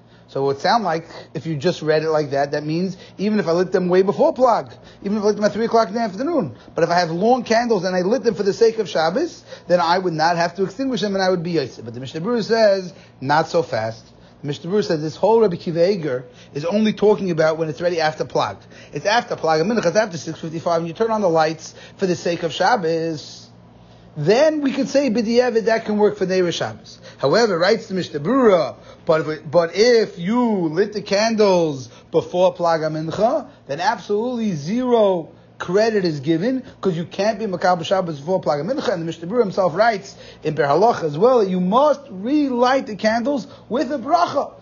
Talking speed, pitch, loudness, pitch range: 220 wpm, 185 Hz, -19 LUFS, 160-225 Hz